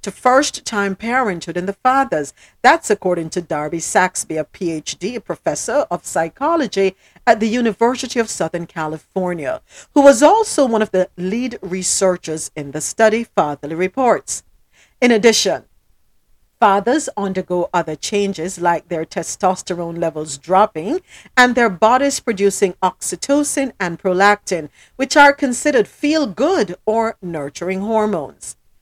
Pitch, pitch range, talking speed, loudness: 195 Hz, 175-245 Hz, 130 wpm, -17 LUFS